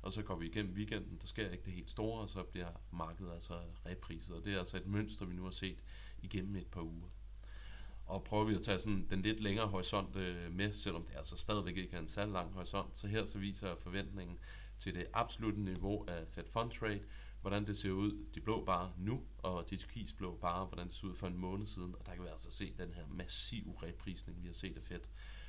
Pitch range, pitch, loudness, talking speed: 90-100 Hz, 95 Hz, -42 LUFS, 240 wpm